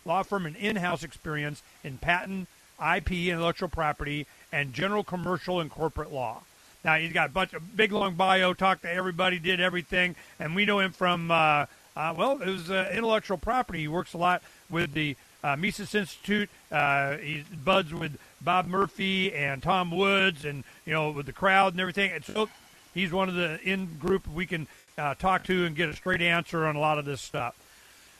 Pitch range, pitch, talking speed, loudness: 155-190 Hz, 180 Hz, 200 wpm, -28 LUFS